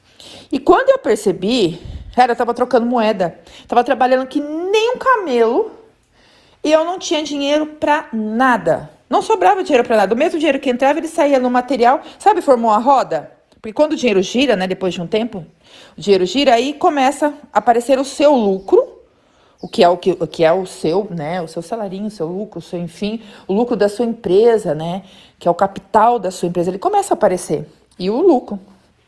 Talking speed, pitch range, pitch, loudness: 205 wpm, 195-295 Hz, 240 Hz, -16 LUFS